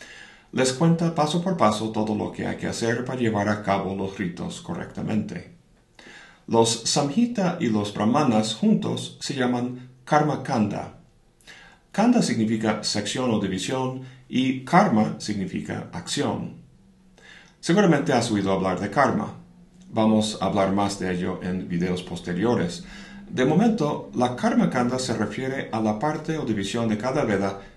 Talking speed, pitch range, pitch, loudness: 145 wpm, 105-160 Hz, 125 Hz, -24 LUFS